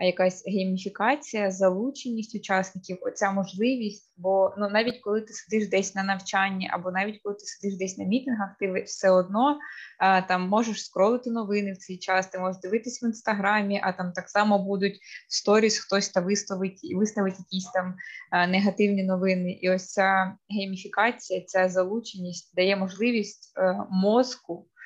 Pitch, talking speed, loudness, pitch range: 195 Hz, 150 wpm, -26 LUFS, 185-210 Hz